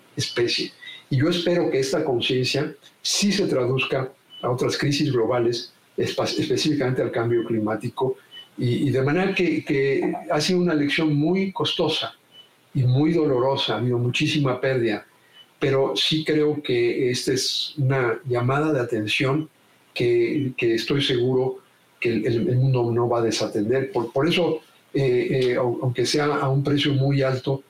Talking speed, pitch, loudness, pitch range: 155 wpm, 135 Hz, -22 LUFS, 125-155 Hz